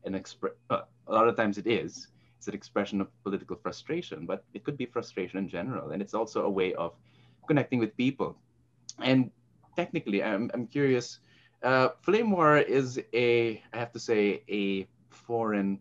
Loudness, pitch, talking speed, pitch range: -30 LUFS, 120 Hz, 180 wpm, 100-130 Hz